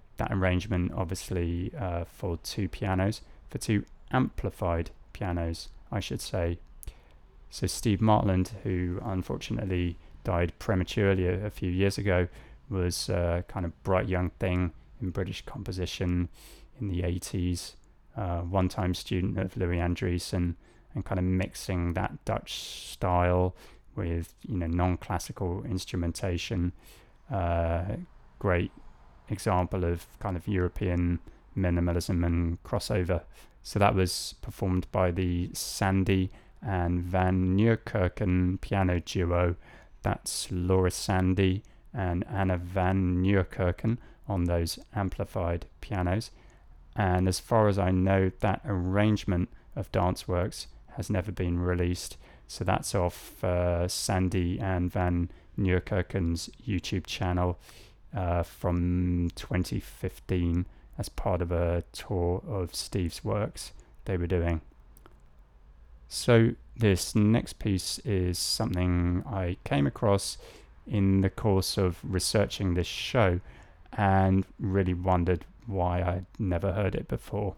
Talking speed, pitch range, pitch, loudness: 120 wpm, 85-95 Hz, 90 Hz, -30 LUFS